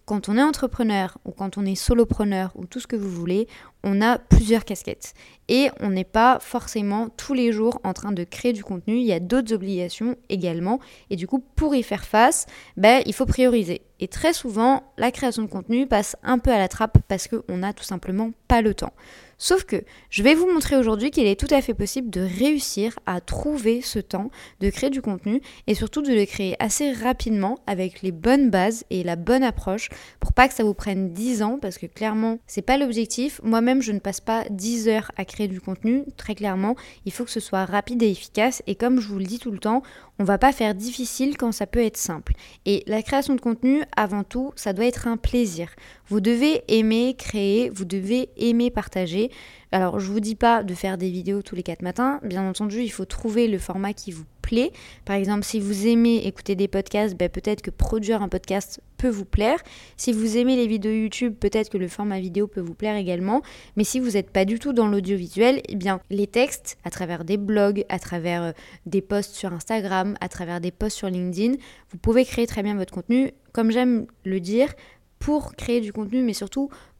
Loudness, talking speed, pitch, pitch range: -23 LUFS, 220 wpm, 215 Hz, 195-245 Hz